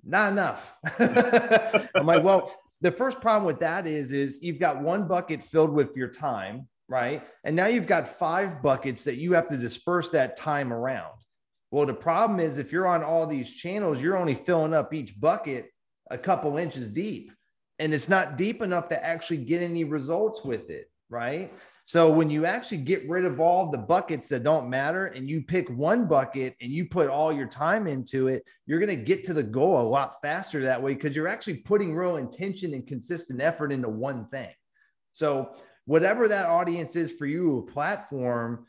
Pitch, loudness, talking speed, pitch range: 165 Hz, -26 LUFS, 195 wpm, 140-185 Hz